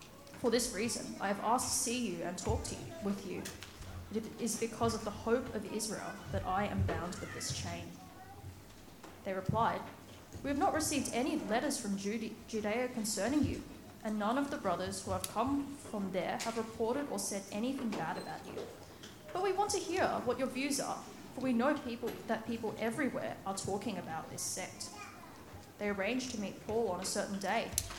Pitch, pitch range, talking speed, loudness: 225 Hz, 195-250 Hz, 195 wpm, -37 LUFS